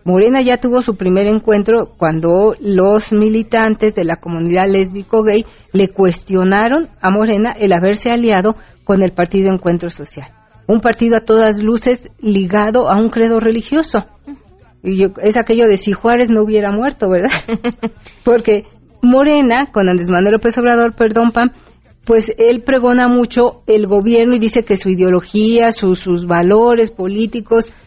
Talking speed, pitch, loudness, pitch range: 150 wpm, 215 Hz, -13 LUFS, 195-235 Hz